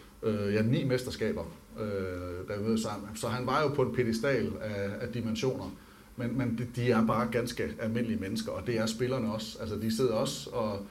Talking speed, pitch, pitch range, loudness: 175 wpm, 110 Hz, 105-120 Hz, -32 LUFS